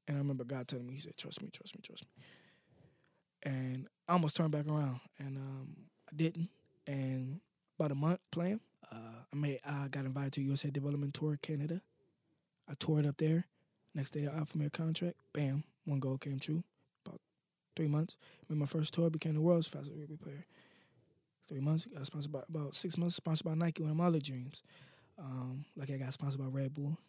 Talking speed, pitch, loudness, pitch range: 205 wpm, 150 Hz, -38 LUFS, 140-165 Hz